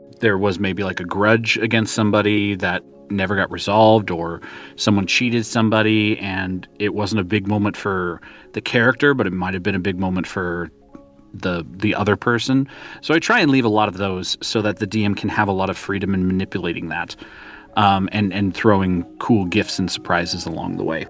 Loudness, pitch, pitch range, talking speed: -19 LUFS, 100 Hz, 95-110 Hz, 200 wpm